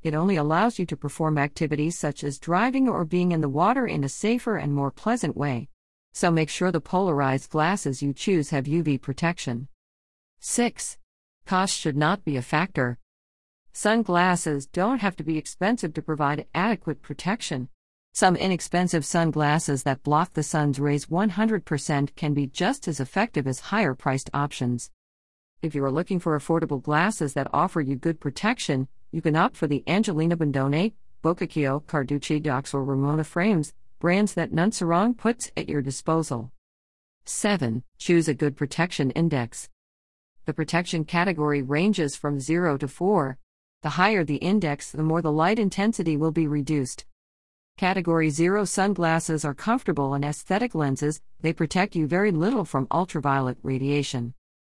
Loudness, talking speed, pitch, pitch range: -25 LUFS, 155 wpm, 155 Hz, 140-180 Hz